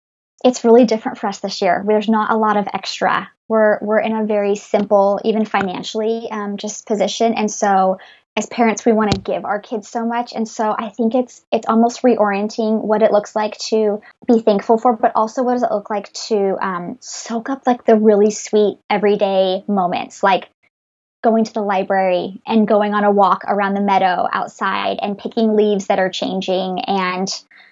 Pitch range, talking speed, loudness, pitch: 200-225 Hz, 195 wpm, -17 LUFS, 215 Hz